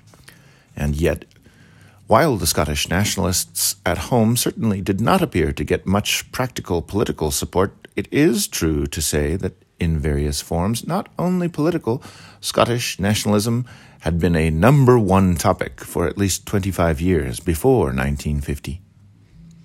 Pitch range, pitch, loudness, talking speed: 80-115 Hz, 95 Hz, -20 LUFS, 135 wpm